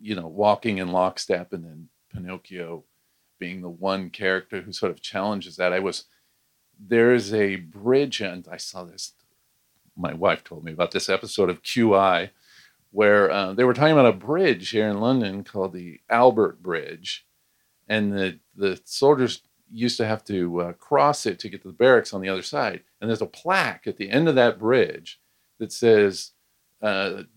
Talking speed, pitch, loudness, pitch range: 180 wpm, 95 Hz, -22 LUFS, 90-110 Hz